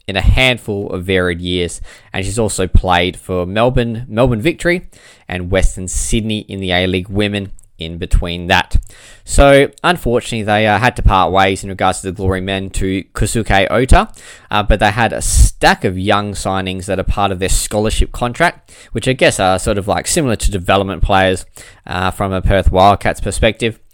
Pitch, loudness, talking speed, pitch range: 95 Hz, -15 LUFS, 190 wpm, 95-110 Hz